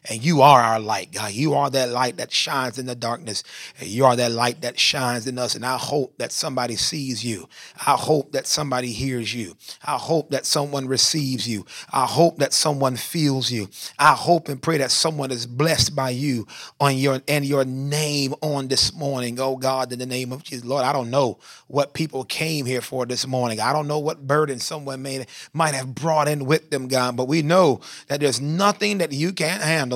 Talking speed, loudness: 215 wpm, -21 LUFS